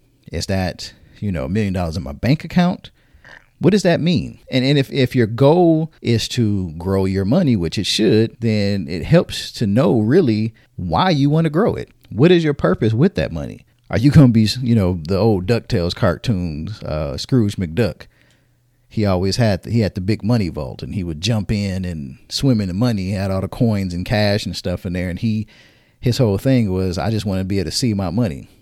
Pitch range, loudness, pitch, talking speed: 95-125 Hz, -18 LUFS, 110 Hz, 230 wpm